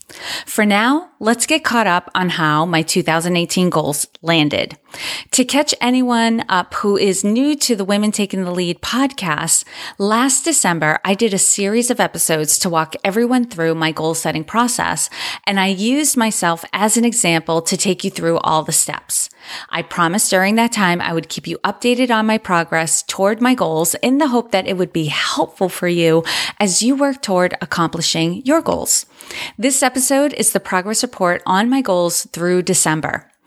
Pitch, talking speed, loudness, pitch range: 190 Hz, 180 wpm, -16 LUFS, 165-235 Hz